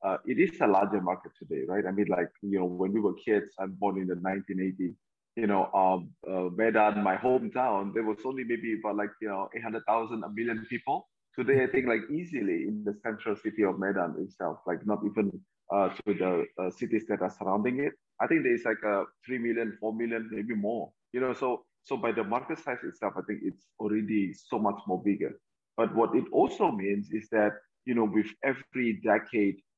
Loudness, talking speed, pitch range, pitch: -30 LUFS, 210 wpm, 100-120 Hz, 110 Hz